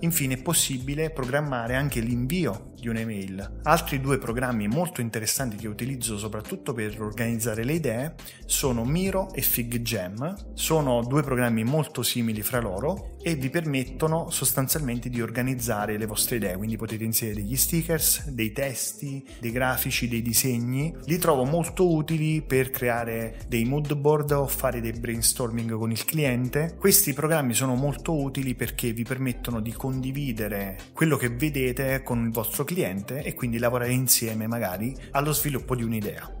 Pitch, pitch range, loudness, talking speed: 125 Hz, 115-145 Hz, -26 LUFS, 155 wpm